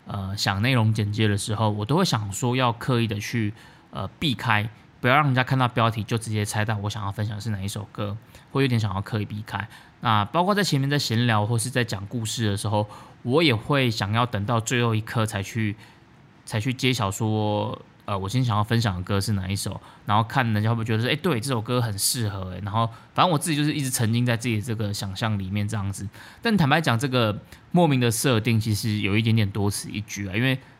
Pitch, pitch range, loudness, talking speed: 110 Hz, 105-125 Hz, -24 LUFS, 335 characters per minute